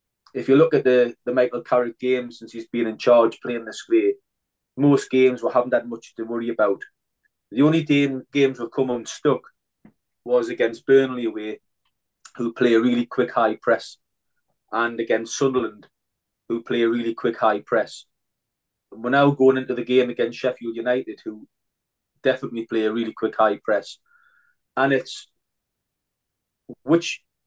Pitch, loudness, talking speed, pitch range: 125 Hz, -22 LUFS, 165 wpm, 115-130 Hz